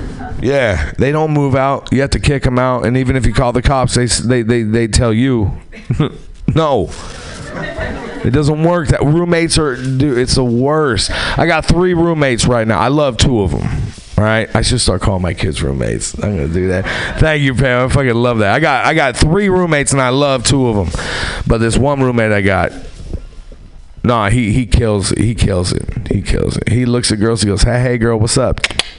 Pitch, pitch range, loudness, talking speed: 120 Hz, 110-135 Hz, -14 LUFS, 220 wpm